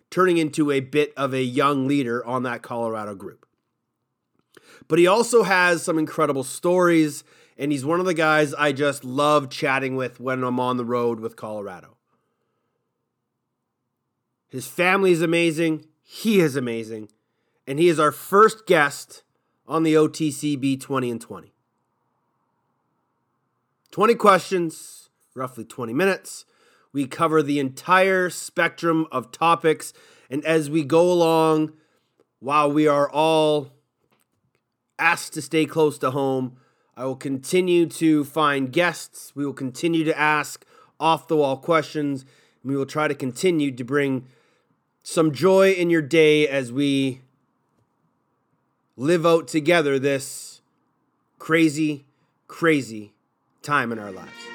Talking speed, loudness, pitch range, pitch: 135 wpm, -21 LUFS, 130-165 Hz, 150 Hz